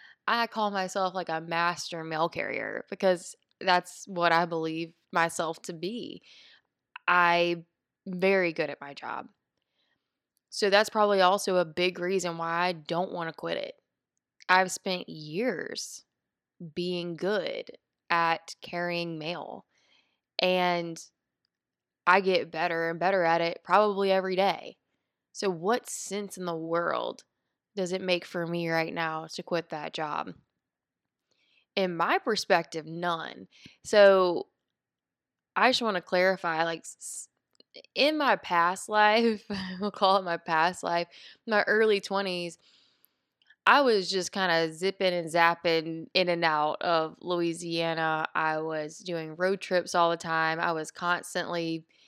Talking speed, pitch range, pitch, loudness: 140 wpm, 165-190 Hz, 175 Hz, -28 LUFS